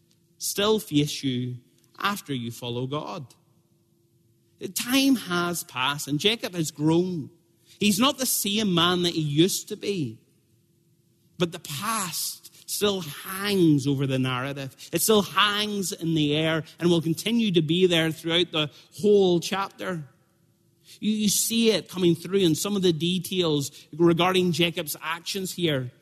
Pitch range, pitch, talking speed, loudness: 150-195 Hz, 170 Hz, 145 wpm, -24 LUFS